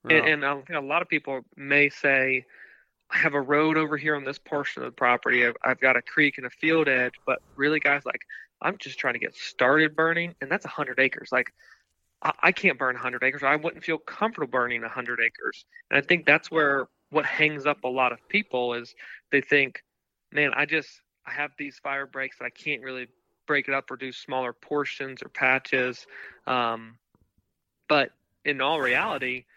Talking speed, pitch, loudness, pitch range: 205 wpm, 140 Hz, -25 LUFS, 130-155 Hz